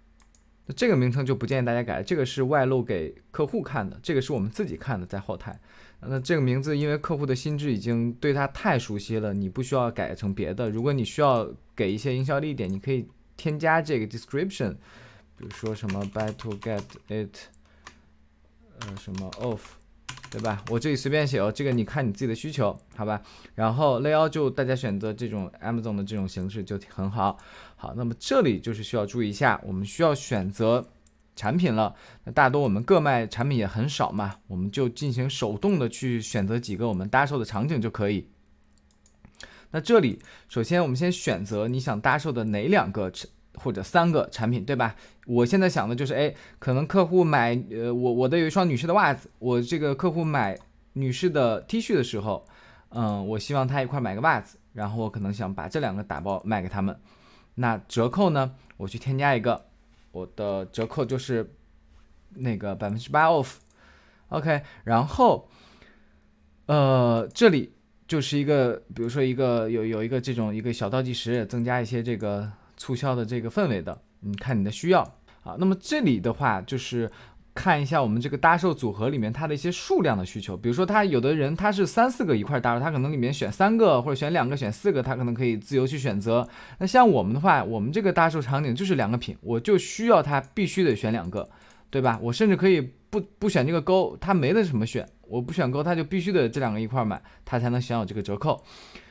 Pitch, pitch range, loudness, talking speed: 120 Hz, 105-145 Hz, -26 LUFS, 325 characters per minute